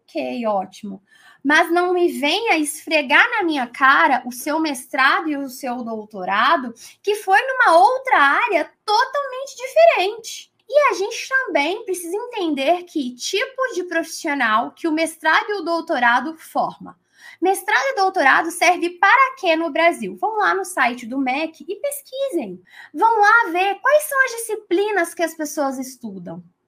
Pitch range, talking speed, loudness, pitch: 275-390 Hz, 155 wpm, -18 LUFS, 330 Hz